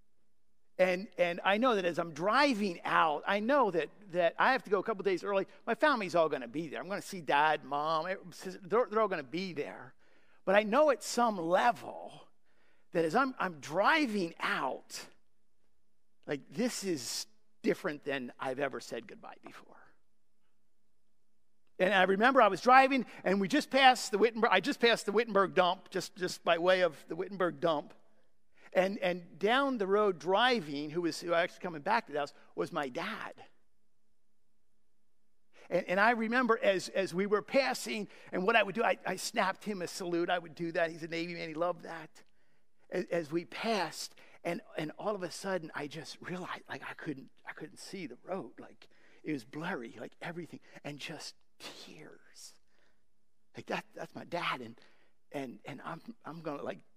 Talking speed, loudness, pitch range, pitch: 185 wpm, -32 LUFS, 165-215 Hz, 185 Hz